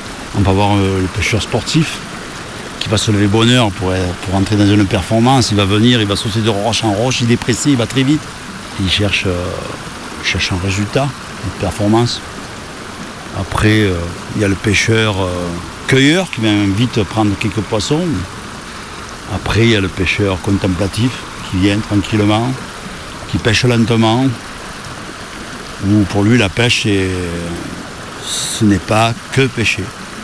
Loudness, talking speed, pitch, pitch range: -14 LUFS, 165 wpm, 105 Hz, 95-115 Hz